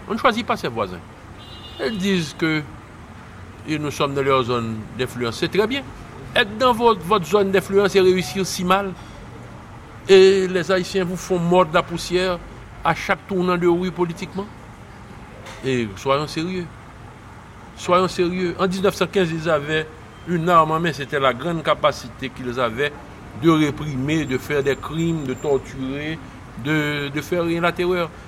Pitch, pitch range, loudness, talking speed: 160 Hz, 125-185 Hz, -20 LUFS, 160 wpm